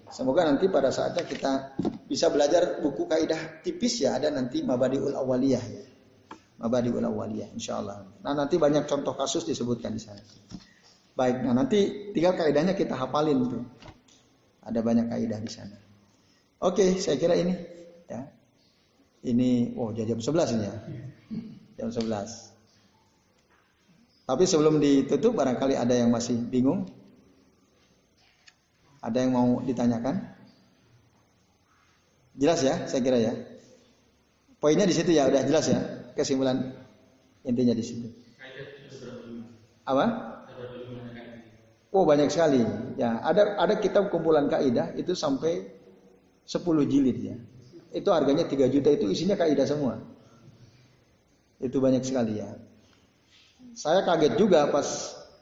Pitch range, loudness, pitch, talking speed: 115-155 Hz, -26 LUFS, 130 Hz, 120 wpm